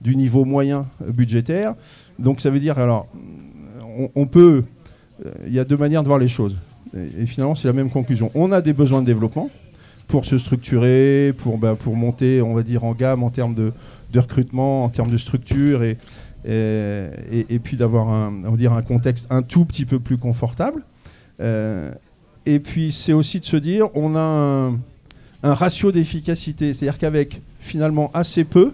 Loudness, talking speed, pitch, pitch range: -19 LUFS, 200 wpm, 130 Hz, 115-145 Hz